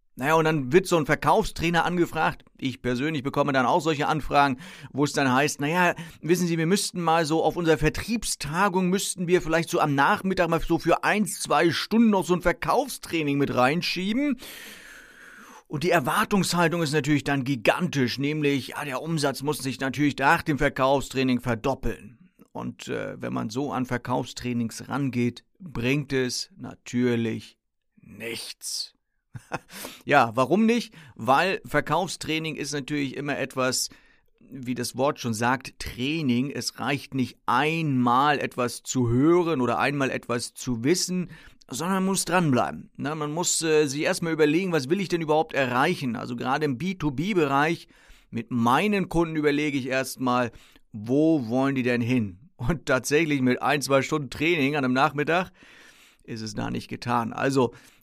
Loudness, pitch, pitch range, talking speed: -25 LUFS, 145 Hz, 130-165 Hz, 155 wpm